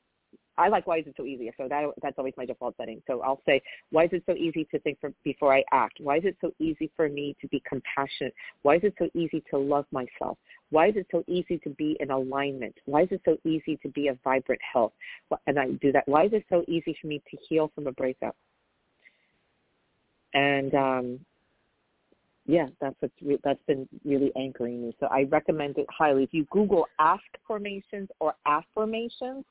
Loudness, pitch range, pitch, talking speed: -28 LUFS, 140-165 Hz, 150 Hz, 210 wpm